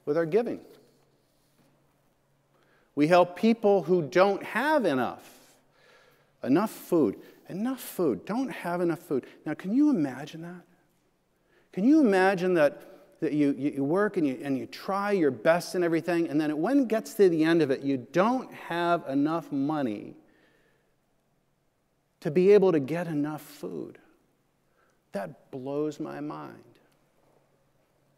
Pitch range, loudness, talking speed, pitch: 150-205 Hz, -26 LUFS, 140 wpm, 175 Hz